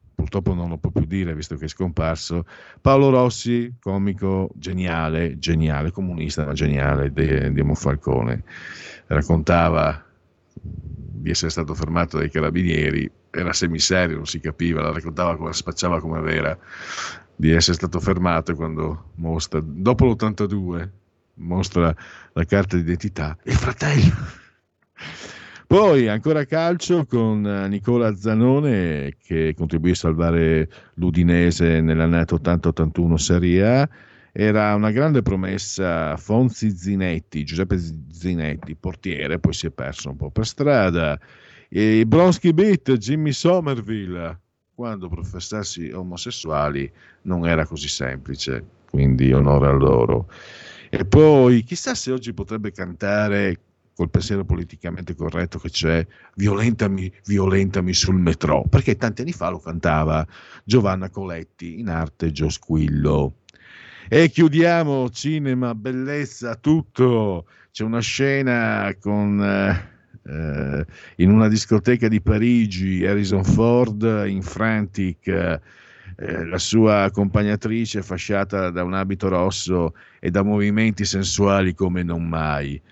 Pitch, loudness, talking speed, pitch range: 90 Hz, -20 LUFS, 120 wpm, 80-110 Hz